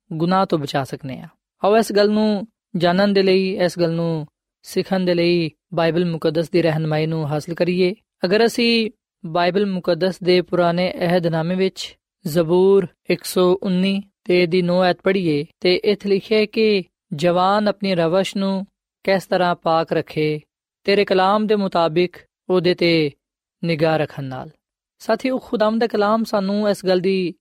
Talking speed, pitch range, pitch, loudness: 155 wpm, 170-200 Hz, 180 Hz, -19 LUFS